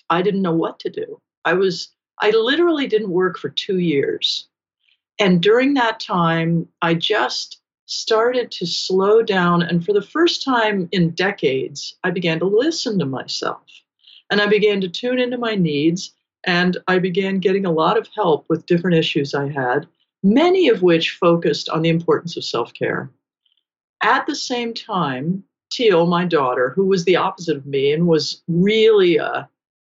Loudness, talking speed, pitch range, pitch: -18 LUFS, 170 wpm, 170-225 Hz, 190 Hz